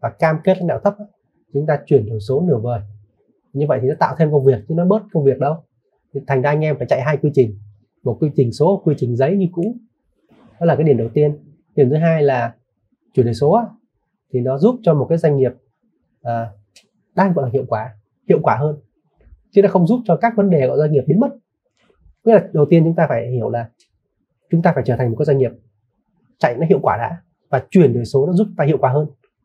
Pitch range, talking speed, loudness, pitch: 125-170 Hz, 245 wpm, -17 LUFS, 150 Hz